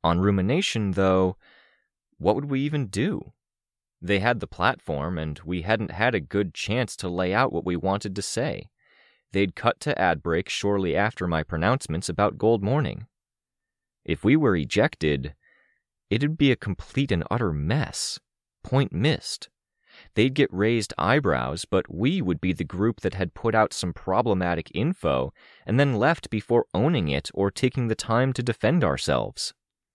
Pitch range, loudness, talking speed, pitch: 90-120 Hz, -25 LUFS, 165 wpm, 100 Hz